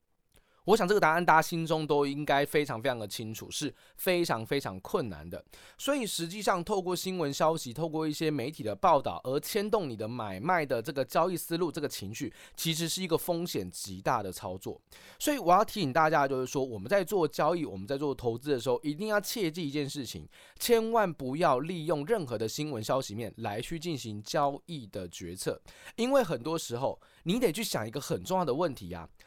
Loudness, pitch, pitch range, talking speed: -31 LUFS, 150 Hz, 120-175 Hz, 320 characters per minute